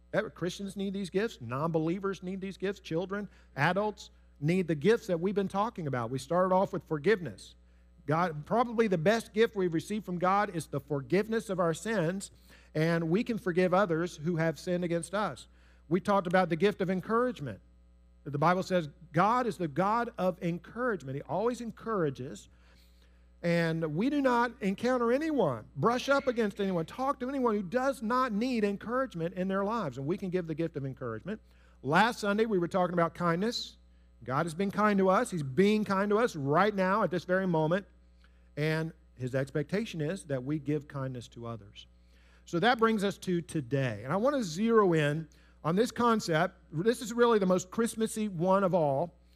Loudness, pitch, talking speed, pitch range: -30 LUFS, 180 Hz, 185 wpm, 150-210 Hz